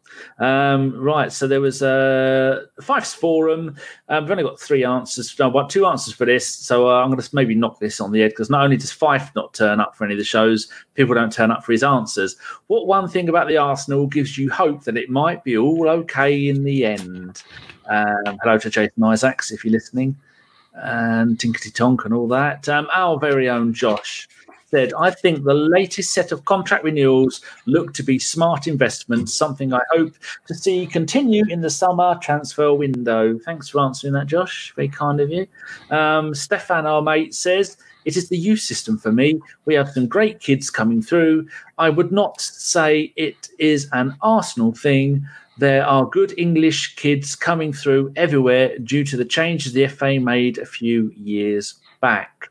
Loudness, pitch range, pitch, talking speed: -18 LUFS, 125-165 Hz, 140 Hz, 195 wpm